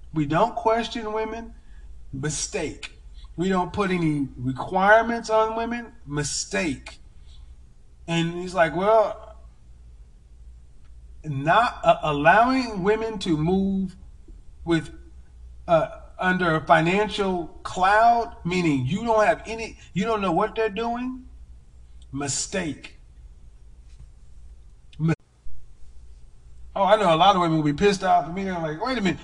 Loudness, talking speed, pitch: -23 LUFS, 125 wpm, 160 Hz